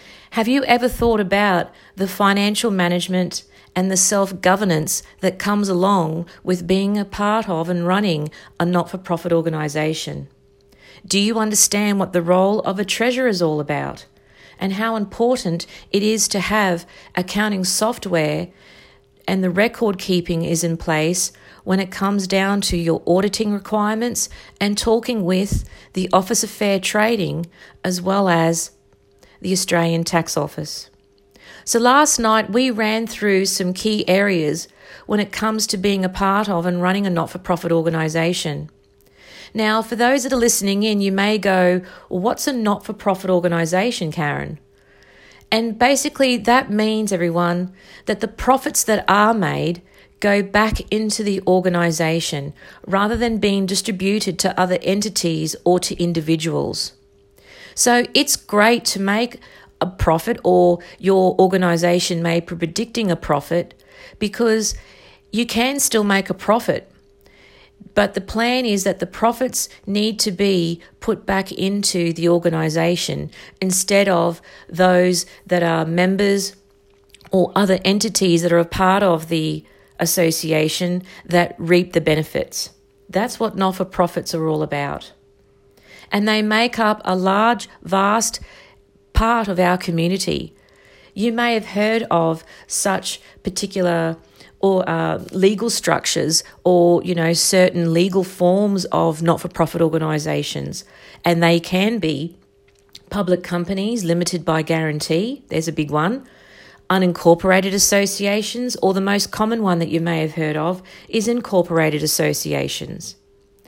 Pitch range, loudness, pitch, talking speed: 165-205 Hz, -18 LUFS, 185 Hz, 140 wpm